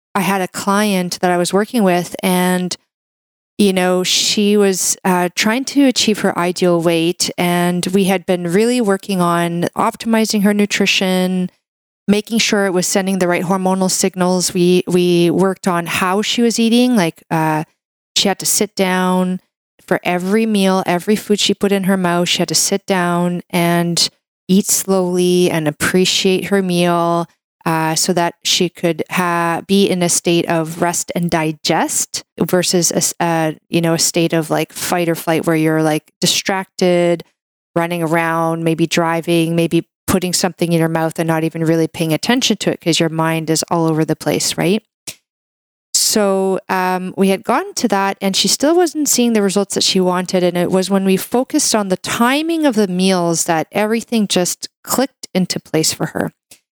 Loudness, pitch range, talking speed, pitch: -15 LUFS, 170-200 Hz, 180 wpm, 180 Hz